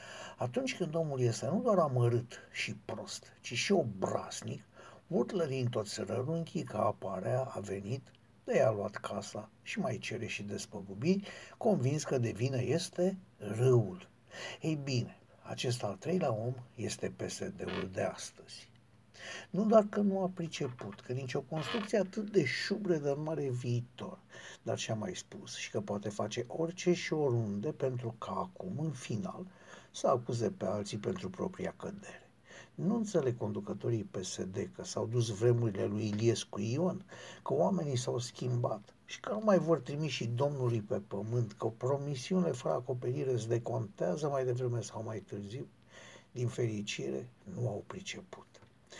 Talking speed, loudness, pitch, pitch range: 155 wpm, -35 LUFS, 125 Hz, 110-160 Hz